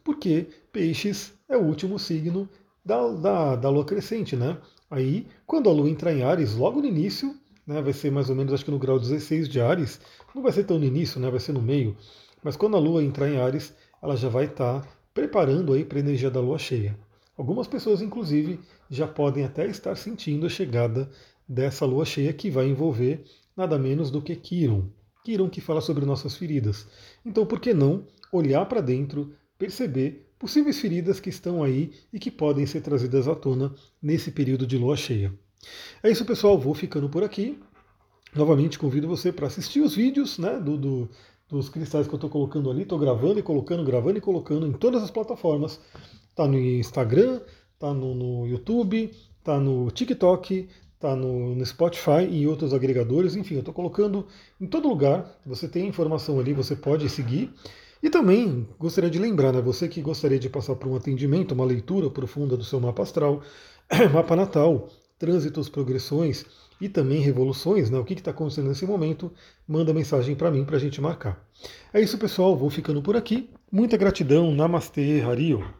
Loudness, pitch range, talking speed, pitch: -25 LUFS, 135-180 Hz, 190 wpm, 150 Hz